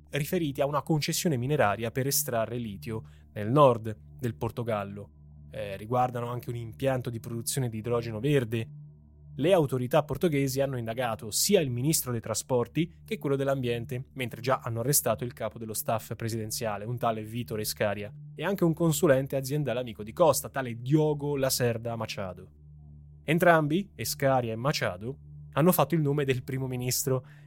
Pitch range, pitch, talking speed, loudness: 110-145 Hz, 125 Hz, 155 wpm, -28 LUFS